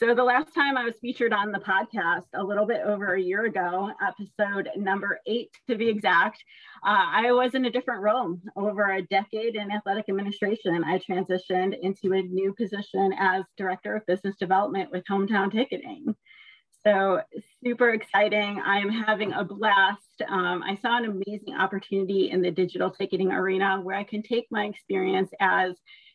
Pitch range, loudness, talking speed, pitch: 190-215 Hz, -26 LUFS, 170 wpm, 200 Hz